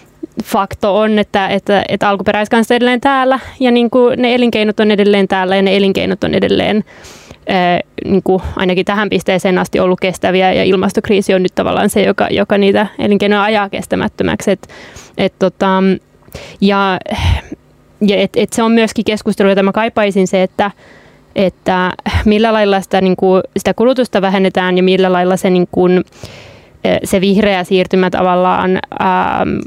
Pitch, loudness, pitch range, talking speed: 195 Hz, -12 LUFS, 190-215 Hz, 155 wpm